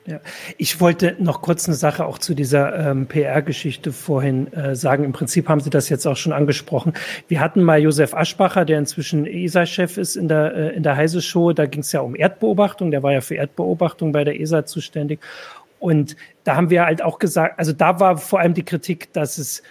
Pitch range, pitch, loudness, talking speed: 150-175 Hz, 160 Hz, -19 LUFS, 215 wpm